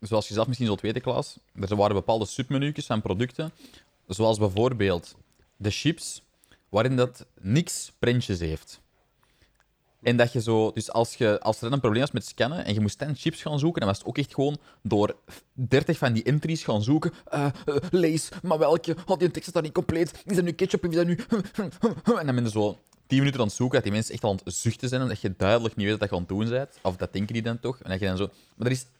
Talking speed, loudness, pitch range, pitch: 245 wpm, -26 LUFS, 105-150 Hz, 120 Hz